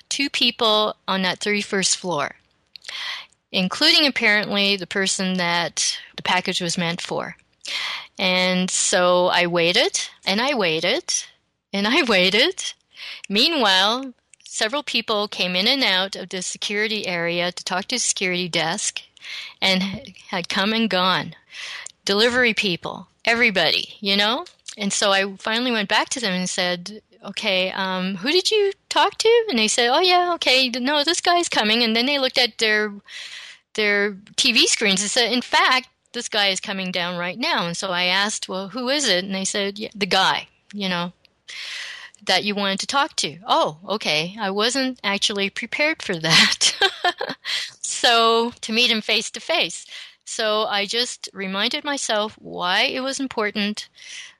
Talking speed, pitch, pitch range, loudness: 160 wpm, 210 Hz, 190-255 Hz, -20 LUFS